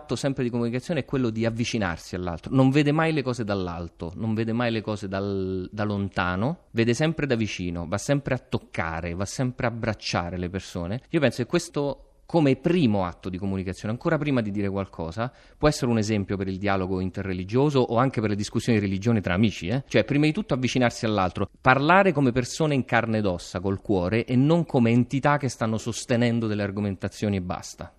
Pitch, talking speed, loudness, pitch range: 115 Hz, 205 wpm, -25 LUFS, 100-130 Hz